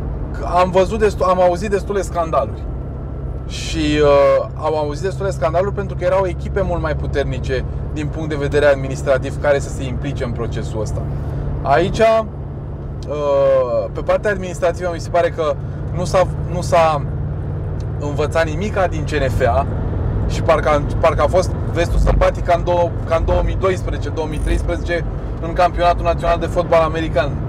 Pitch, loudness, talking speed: 145 Hz, -18 LUFS, 145 wpm